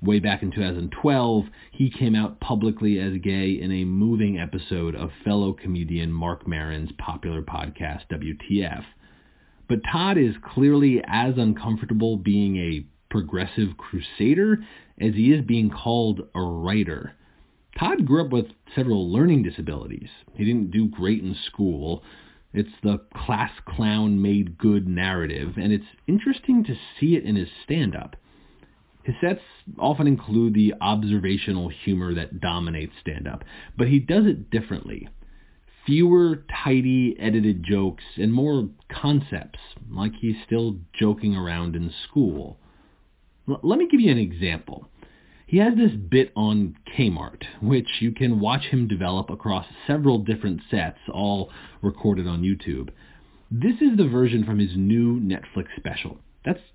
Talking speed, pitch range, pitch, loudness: 140 wpm, 90-115 Hz, 105 Hz, -23 LUFS